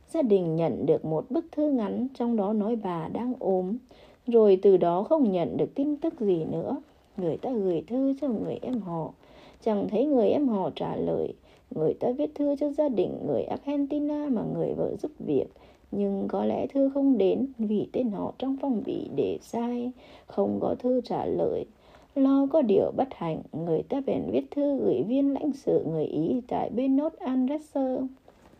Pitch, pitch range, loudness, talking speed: 255 Hz, 210-285 Hz, -27 LUFS, 190 wpm